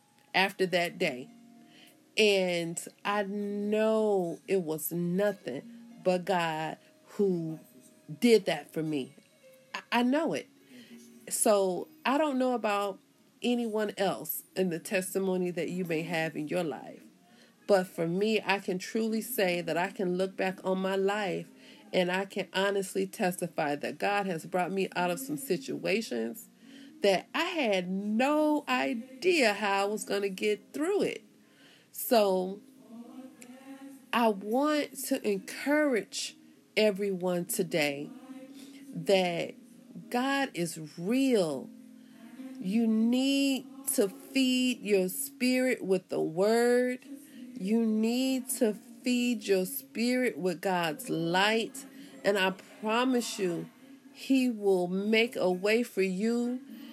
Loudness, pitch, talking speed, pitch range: -30 LUFS, 215 Hz, 125 wpm, 185-255 Hz